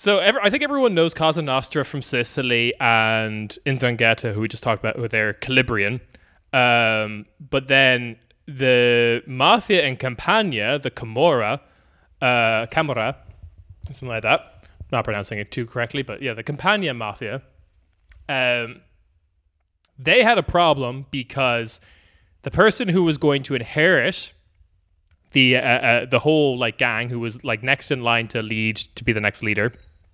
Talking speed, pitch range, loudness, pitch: 155 wpm, 105-135 Hz, -20 LUFS, 120 Hz